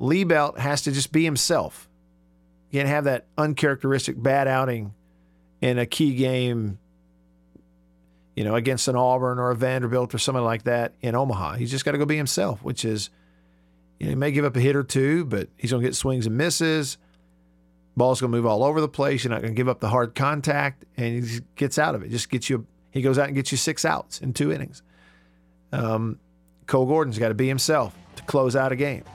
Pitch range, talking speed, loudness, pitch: 100-140 Hz, 220 wpm, -24 LUFS, 125 Hz